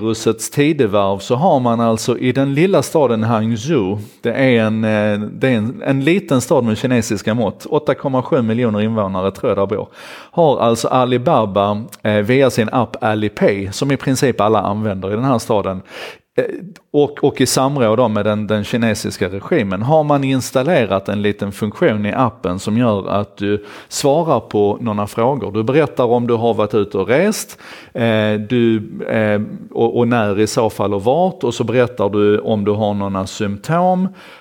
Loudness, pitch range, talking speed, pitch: -16 LUFS, 105-130 Hz, 165 wpm, 110 Hz